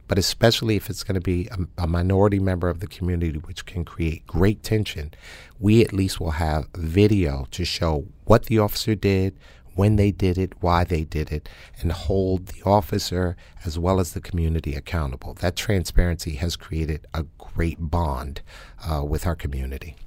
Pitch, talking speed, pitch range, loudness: 85 Hz, 180 wpm, 80-95 Hz, -24 LUFS